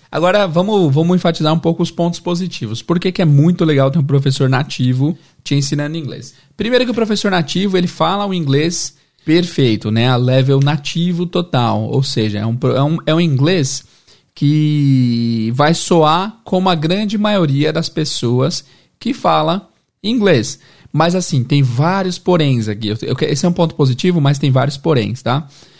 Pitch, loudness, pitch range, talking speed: 155 Hz, -15 LUFS, 135-175 Hz, 175 wpm